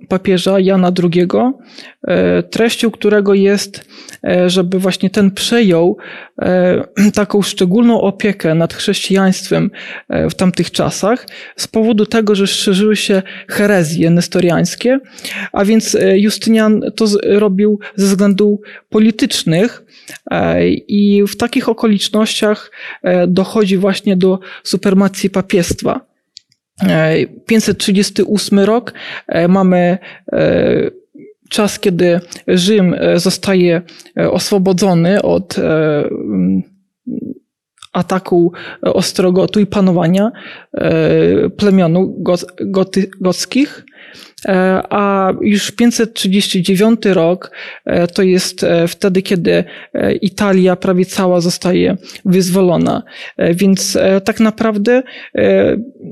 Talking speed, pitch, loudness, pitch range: 80 wpm, 195 Hz, -13 LUFS, 185-215 Hz